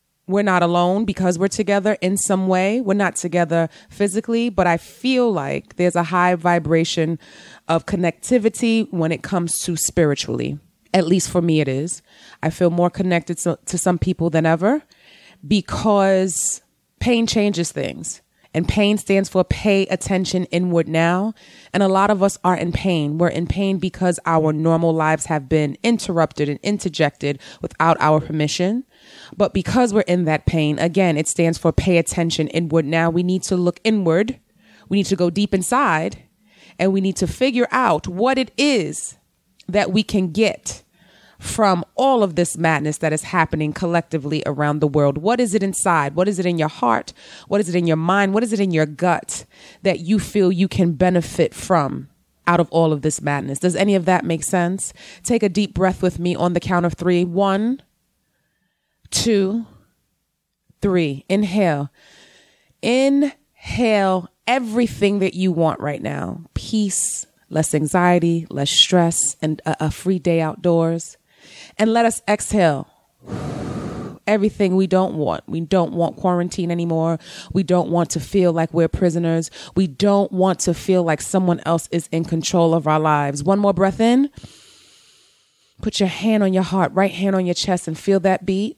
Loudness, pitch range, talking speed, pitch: -19 LUFS, 165-195 Hz, 175 wpm, 180 Hz